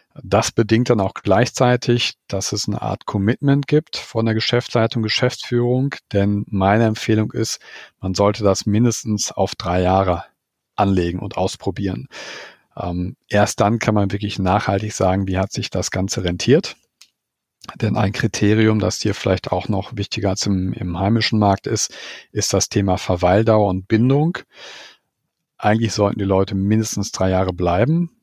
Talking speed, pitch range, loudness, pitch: 150 wpm, 95-115 Hz, -19 LUFS, 105 Hz